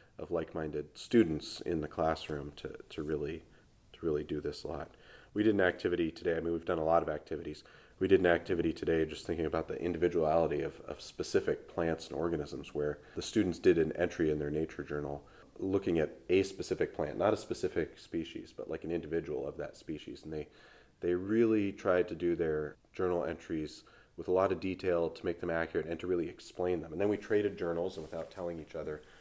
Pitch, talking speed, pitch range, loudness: 85 Hz, 210 wpm, 80-90 Hz, -34 LUFS